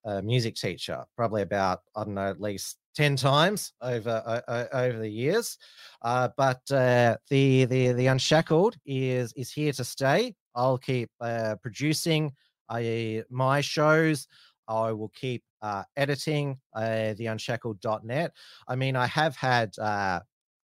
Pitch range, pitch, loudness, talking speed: 110-140 Hz, 125 Hz, -27 LUFS, 145 wpm